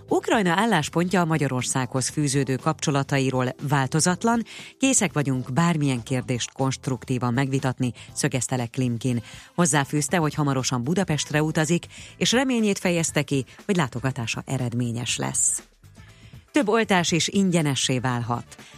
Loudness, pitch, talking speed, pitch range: -23 LUFS, 140 Hz, 110 wpm, 125-170 Hz